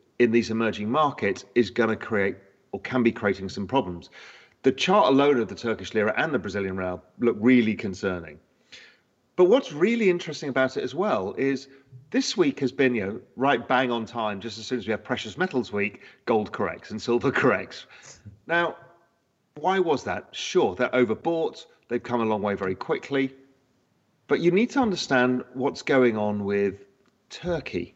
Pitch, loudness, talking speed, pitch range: 120 Hz, -25 LUFS, 180 wpm, 105-135 Hz